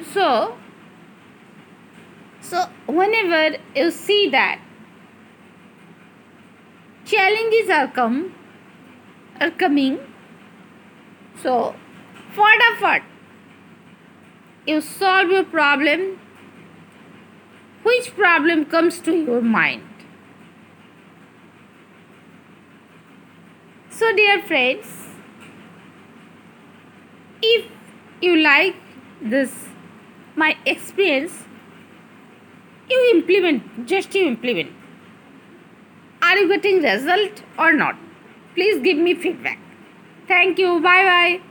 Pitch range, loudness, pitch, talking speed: 280-385 Hz, -17 LUFS, 345 Hz, 75 wpm